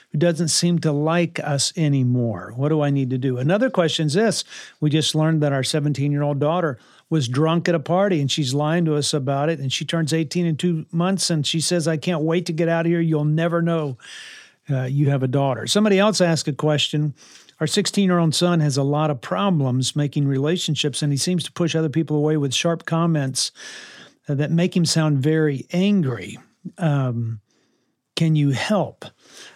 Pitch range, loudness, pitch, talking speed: 145-170 Hz, -21 LUFS, 155 Hz, 205 wpm